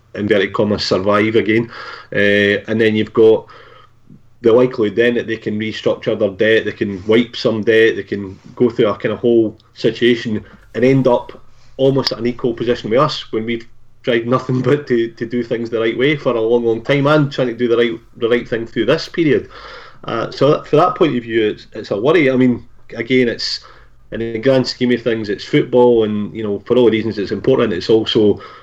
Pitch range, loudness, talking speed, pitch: 110-125 Hz, -16 LUFS, 220 wpm, 115 Hz